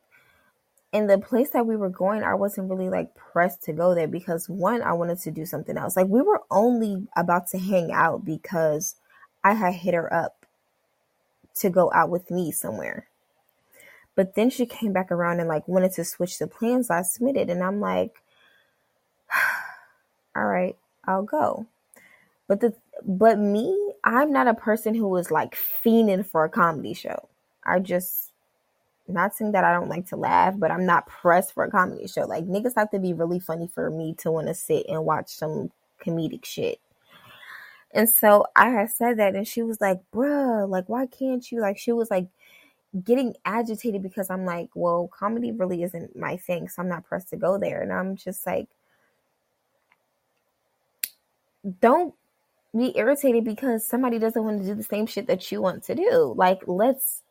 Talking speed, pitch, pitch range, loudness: 185 wpm, 195 Hz, 180-235 Hz, -24 LUFS